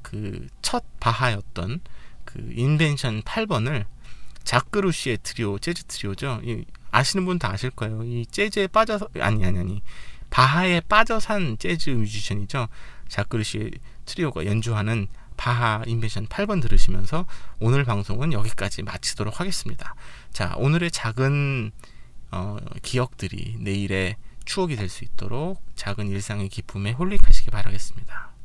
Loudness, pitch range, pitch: -25 LUFS, 100-145 Hz, 115 Hz